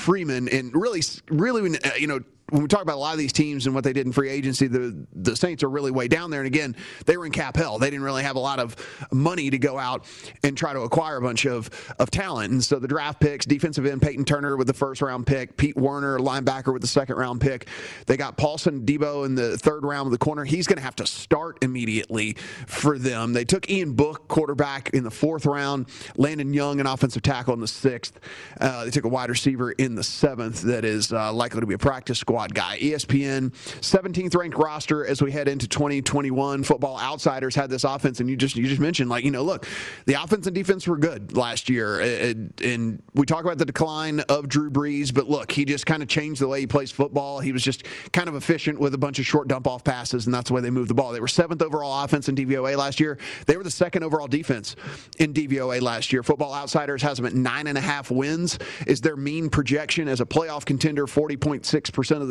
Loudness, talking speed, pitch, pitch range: -24 LUFS, 245 wpm, 140 Hz, 130-150 Hz